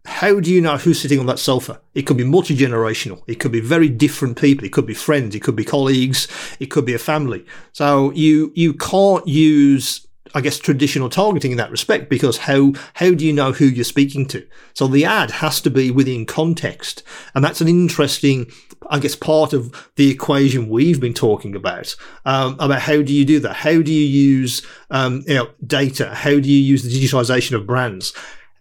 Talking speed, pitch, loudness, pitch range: 210 wpm, 140 Hz, -16 LUFS, 130-150 Hz